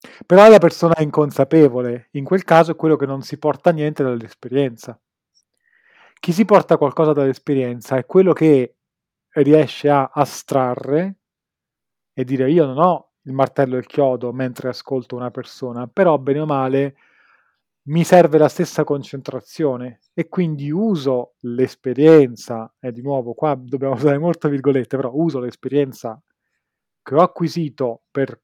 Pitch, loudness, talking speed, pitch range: 140 Hz, -17 LUFS, 150 wpm, 130-165 Hz